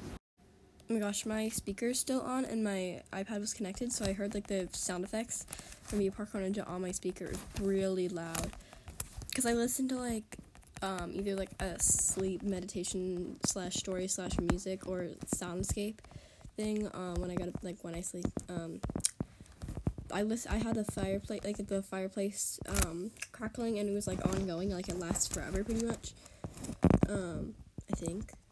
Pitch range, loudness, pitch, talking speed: 185-215 Hz, -36 LUFS, 195 Hz, 170 wpm